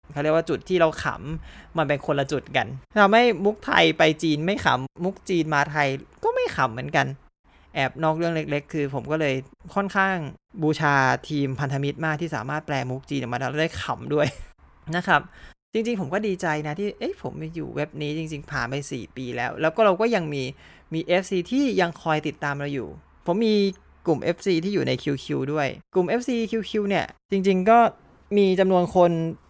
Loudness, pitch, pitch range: -24 LUFS, 160 Hz, 145-190 Hz